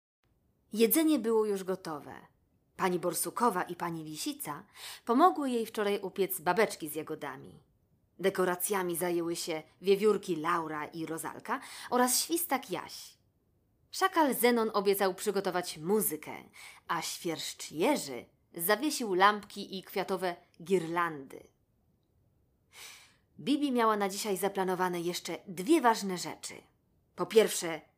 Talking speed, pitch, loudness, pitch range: 105 wpm, 190 Hz, -31 LUFS, 170-215 Hz